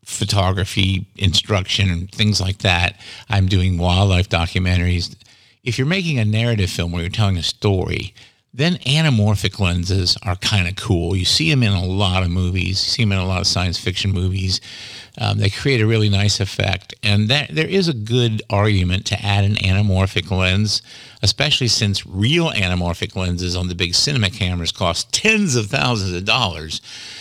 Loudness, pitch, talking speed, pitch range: -18 LUFS, 100 Hz, 180 wpm, 95-115 Hz